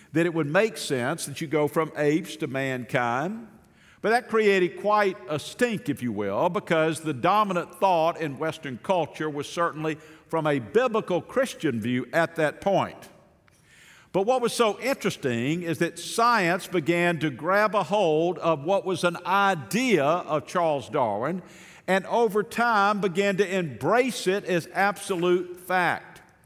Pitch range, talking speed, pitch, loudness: 155-200 Hz, 155 wpm, 175 Hz, -25 LUFS